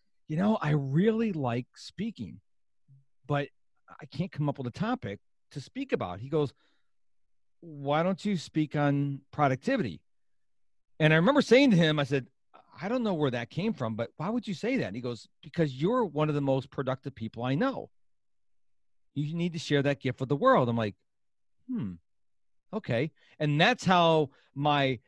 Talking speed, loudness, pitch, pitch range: 180 wpm, -29 LUFS, 145 Hz, 125-175 Hz